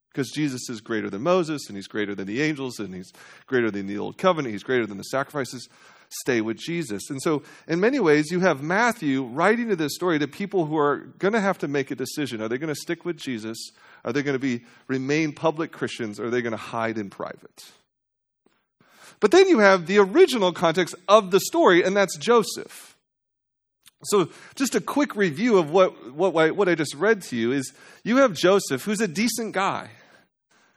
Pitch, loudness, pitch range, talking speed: 155 Hz, -23 LUFS, 125-195 Hz, 210 wpm